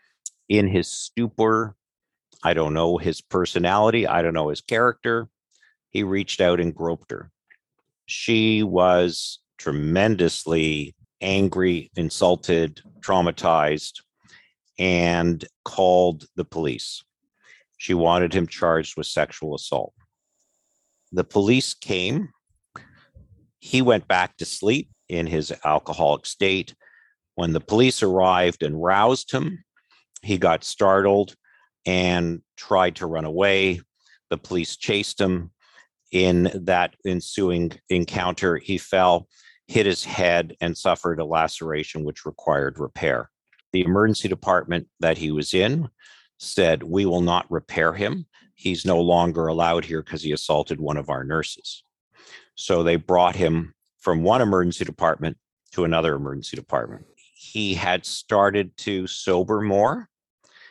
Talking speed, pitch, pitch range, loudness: 125 wpm, 90 Hz, 85-100 Hz, -22 LUFS